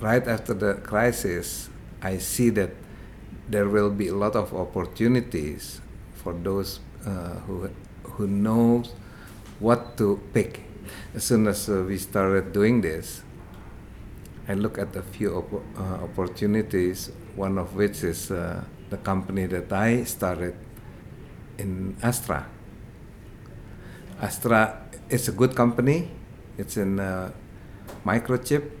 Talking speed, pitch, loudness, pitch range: 125 wpm, 100 Hz, -26 LUFS, 95-115 Hz